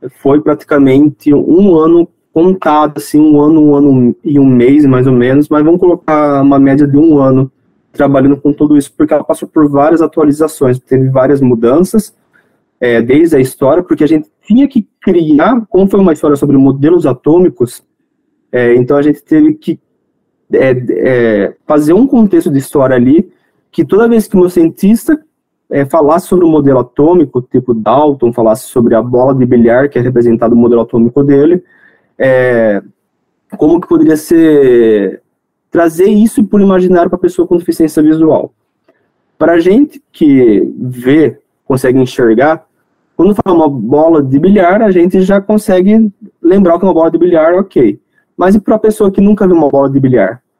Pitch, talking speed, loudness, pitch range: 155 Hz, 175 wpm, -8 LUFS, 135-190 Hz